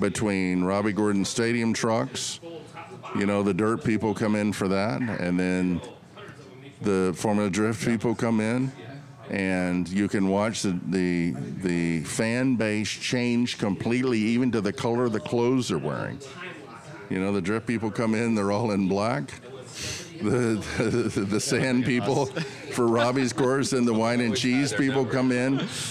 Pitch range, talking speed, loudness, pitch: 100-125 Hz, 160 wpm, -25 LUFS, 115 Hz